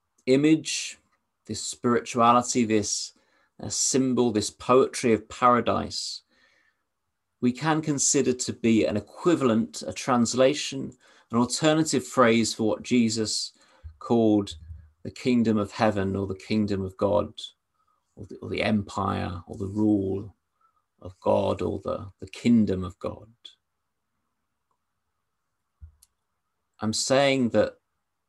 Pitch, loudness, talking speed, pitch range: 110 Hz, -25 LUFS, 115 wpm, 100-125 Hz